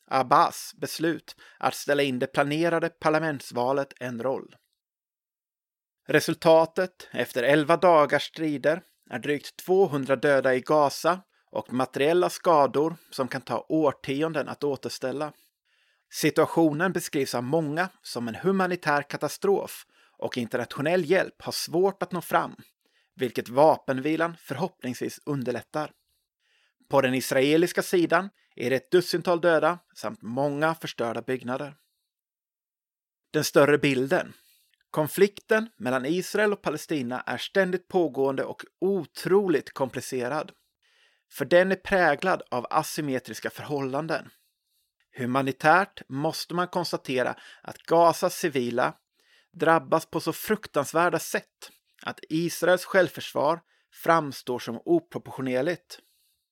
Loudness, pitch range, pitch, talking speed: -26 LUFS, 135-175 Hz, 155 Hz, 110 wpm